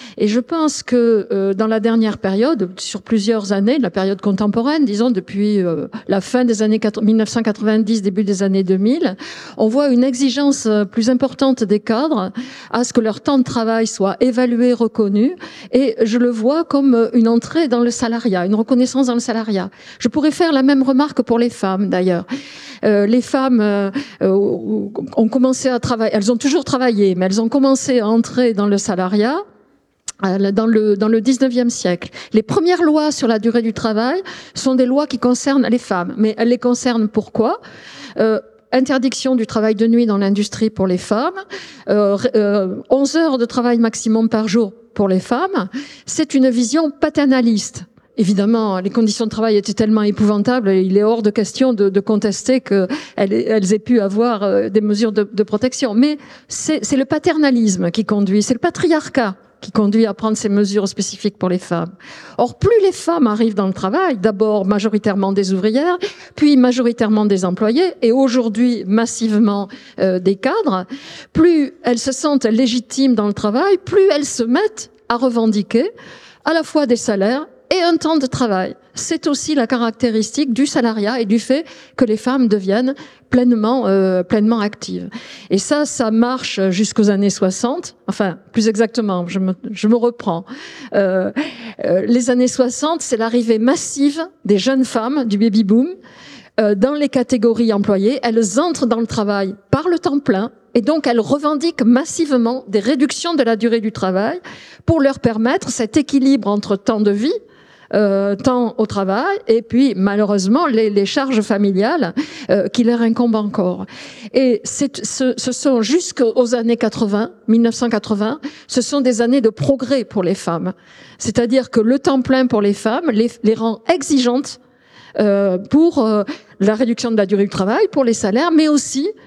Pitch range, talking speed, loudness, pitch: 210-265 Hz, 175 wpm, -16 LUFS, 230 Hz